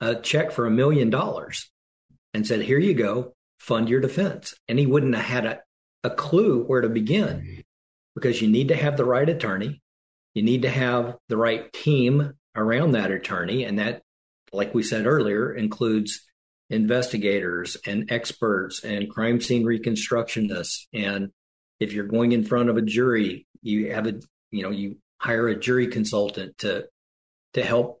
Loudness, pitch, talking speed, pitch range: -24 LUFS, 115 Hz, 170 wpm, 105-125 Hz